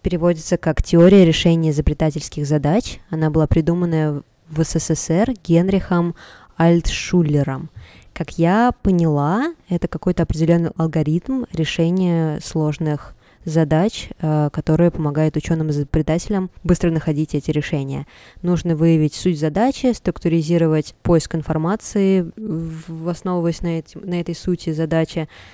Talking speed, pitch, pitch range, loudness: 105 wpm, 165 Hz, 155-175 Hz, -19 LUFS